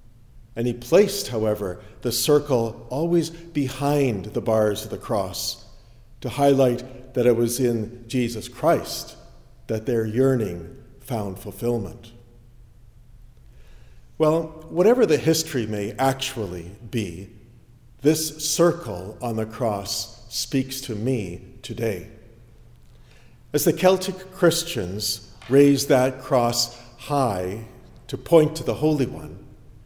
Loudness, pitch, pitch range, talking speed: -23 LUFS, 120 Hz, 110-135 Hz, 115 wpm